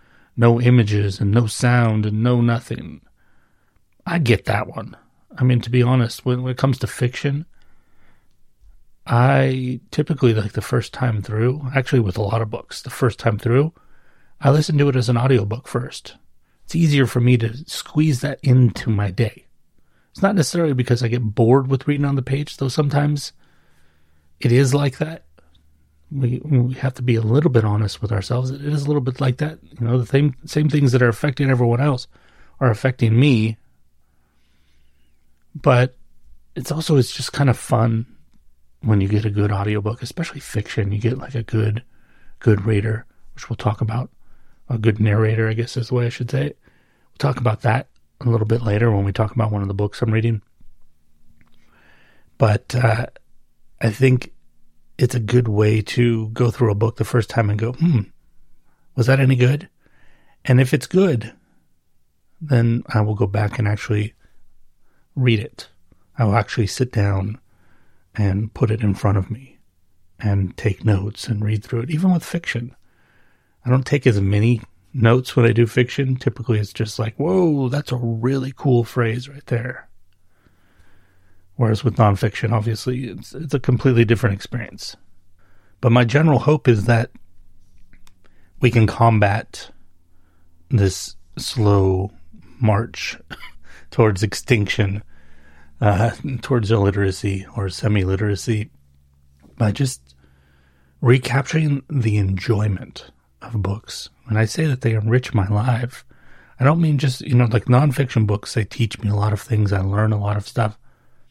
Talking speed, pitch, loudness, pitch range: 170 wpm, 115 Hz, -19 LUFS, 100-125 Hz